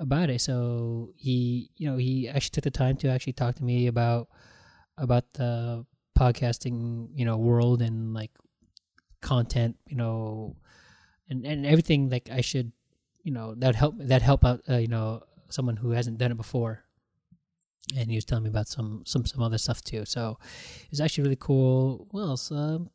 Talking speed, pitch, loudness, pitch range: 185 wpm, 125 Hz, -28 LUFS, 115-135 Hz